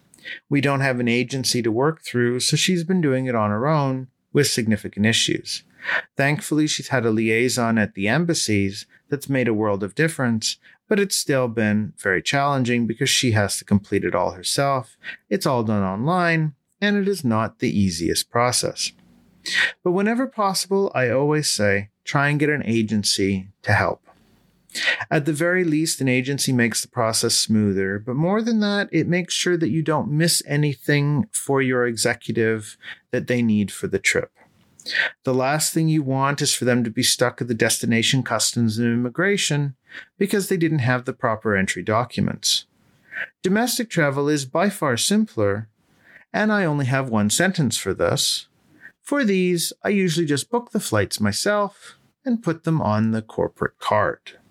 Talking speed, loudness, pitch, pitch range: 175 wpm, -21 LUFS, 135 Hz, 115-165 Hz